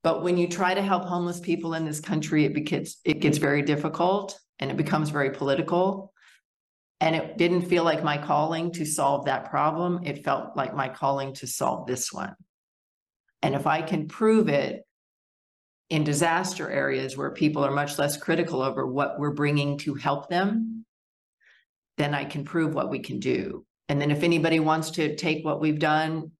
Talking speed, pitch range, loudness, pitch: 185 wpm, 145-170 Hz, -26 LUFS, 155 Hz